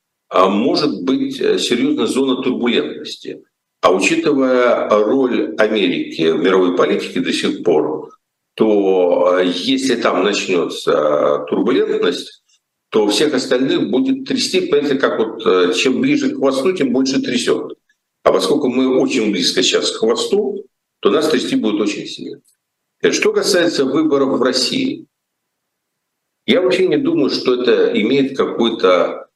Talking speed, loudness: 125 wpm, -15 LUFS